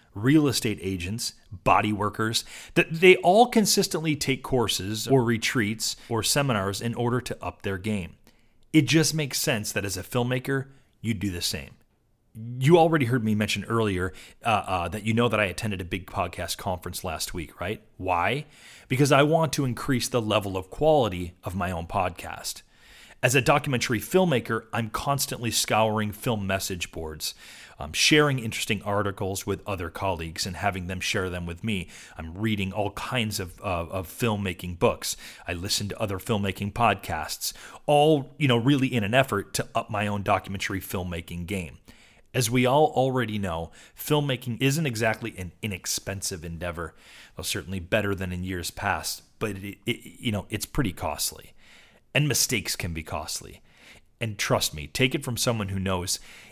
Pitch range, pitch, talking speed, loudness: 95-125 Hz, 105 Hz, 170 wpm, -26 LUFS